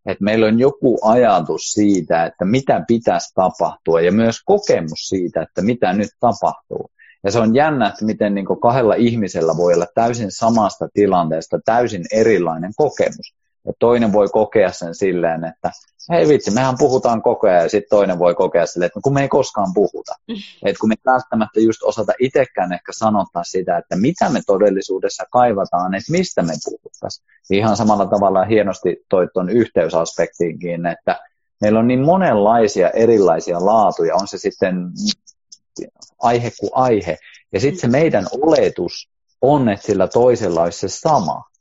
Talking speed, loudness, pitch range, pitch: 160 wpm, -16 LUFS, 95-125 Hz, 110 Hz